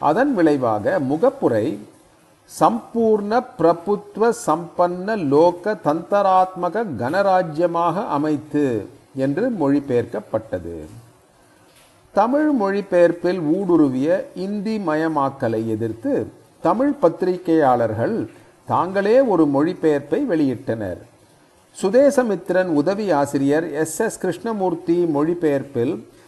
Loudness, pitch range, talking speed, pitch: -20 LUFS, 145-205 Hz, 65 wpm, 175 Hz